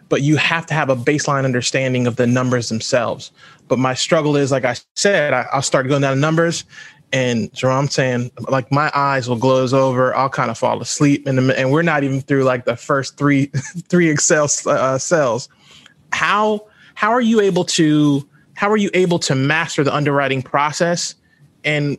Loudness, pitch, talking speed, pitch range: -17 LUFS, 140 Hz, 195 wpm, 130-155 Hz